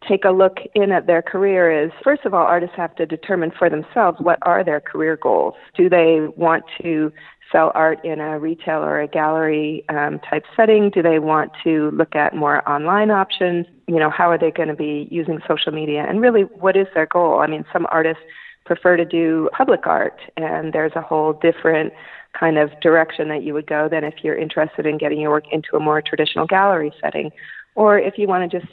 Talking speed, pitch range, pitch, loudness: 215 wpm, 155-175 Hz, 160 Hz, -18 LUFS